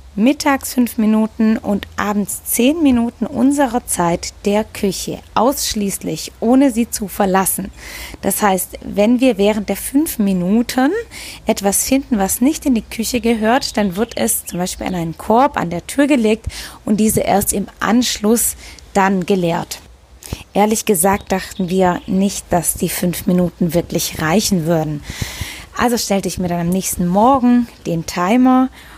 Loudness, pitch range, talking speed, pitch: -16 LUFS, 185-245 Hz, 150 wpm, 210 Hz